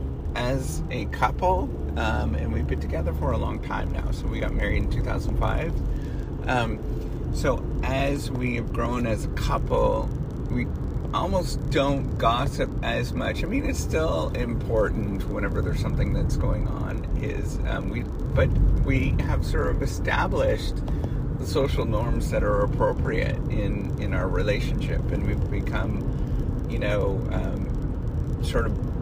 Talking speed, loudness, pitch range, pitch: 155 wpm, -26 LUFS, 75-120 Hz, 85 Hz